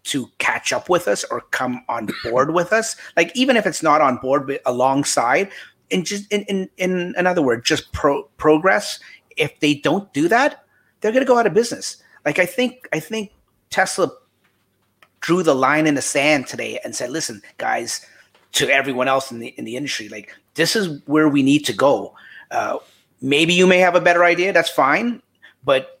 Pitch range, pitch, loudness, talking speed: 140-205 Hz, 170 Hz, -19 LUFS, 195 wpm